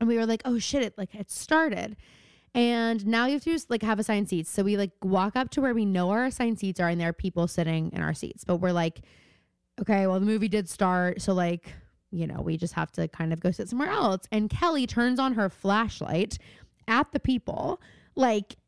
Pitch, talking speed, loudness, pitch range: 205 Hz, 240 wpm, -27 LUFS, 180-240 Hz